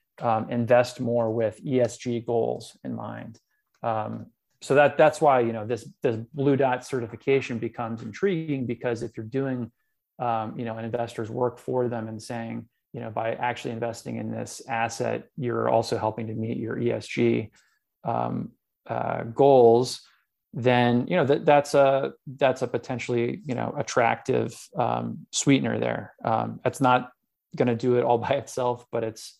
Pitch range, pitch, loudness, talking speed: 115-130 Hz, 120 Hz, -25 LUFS, 165 wpm